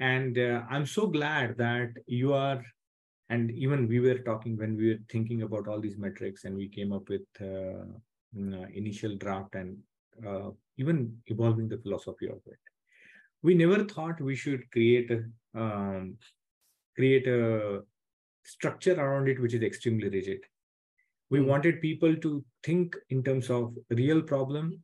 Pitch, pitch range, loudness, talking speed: 120 Hz, 105-135 Hz, -30 LUFS, 155 wpm